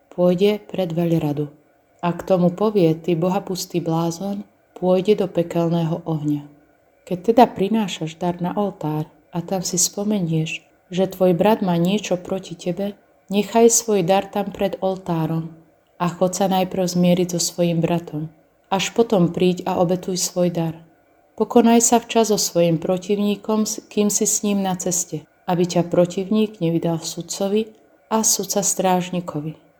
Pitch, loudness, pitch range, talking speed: 180 Hz, -20 LUFS, 170-205 Hz, 145 wpm